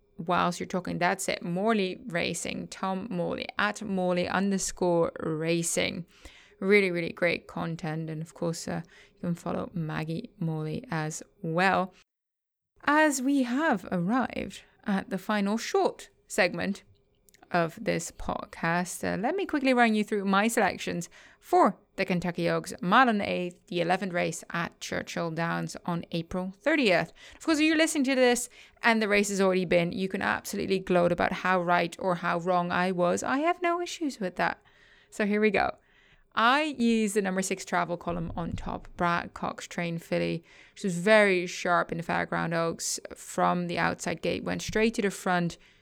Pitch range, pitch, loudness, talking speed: 170-215 Hz, 185 Hz, -28 LUFS, 170 wpm